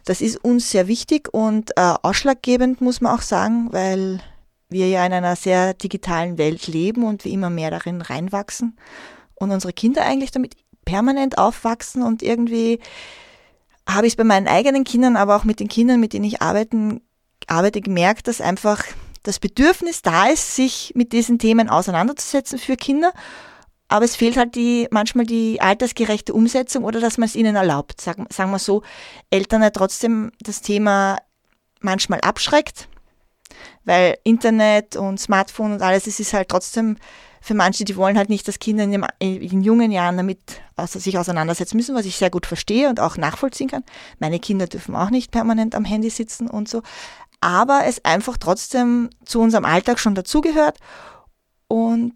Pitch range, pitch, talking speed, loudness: 190-240 Hz, 215 Hz, 170 wpm, -19 LUFS